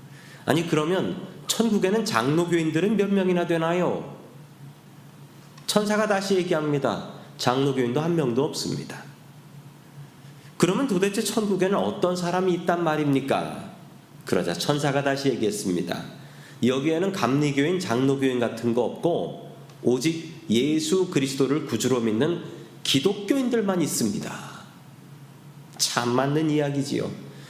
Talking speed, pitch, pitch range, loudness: 280 characters per minute, 150 Hz, 140-180 Hz, -24 LUFS